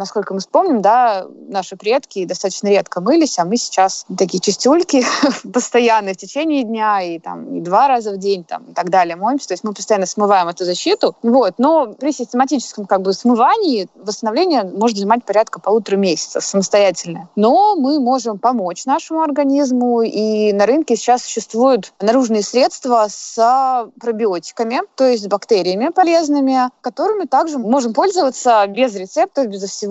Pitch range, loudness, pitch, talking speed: 200-265 Hz, -16 LUFS, 230 Hz, 160 wpm